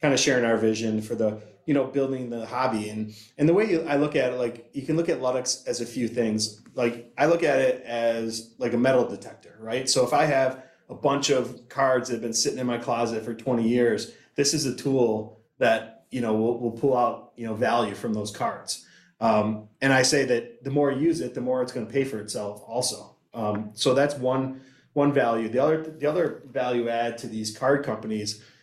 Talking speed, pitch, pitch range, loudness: 235 wpm, 120 Hz, 115-130 Hz, -25 LUFS